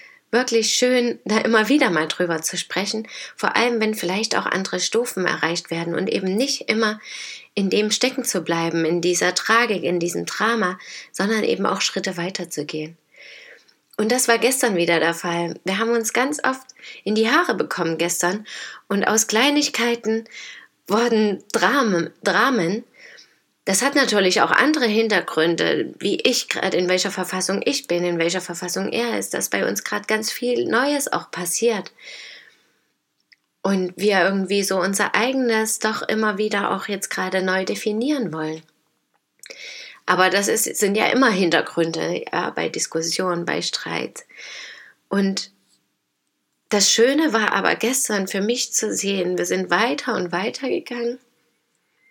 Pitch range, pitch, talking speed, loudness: 180-235 Hz, 205 Hz, 150 wpm, -20 LUFS